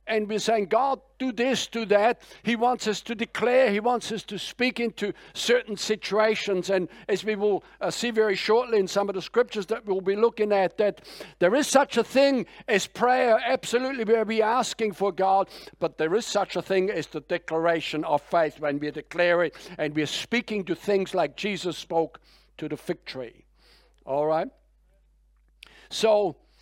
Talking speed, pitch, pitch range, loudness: 185 wpm, 205 Hz, 175-230 Hz, -25 LUFS